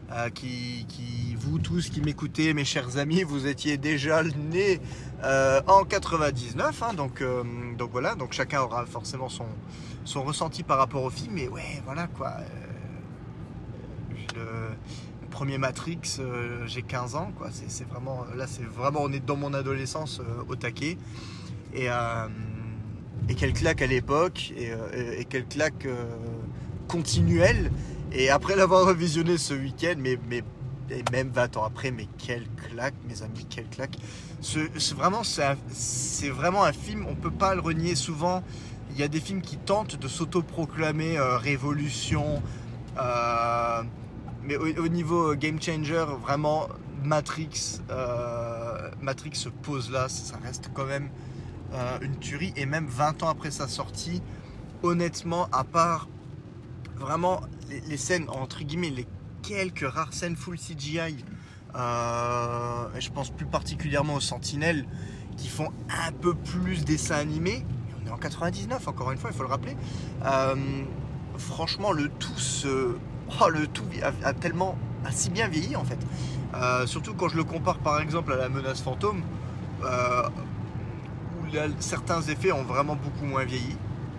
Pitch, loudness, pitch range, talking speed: 135 Hz, -29 LUFS, 120-155 Hz, 160 wpm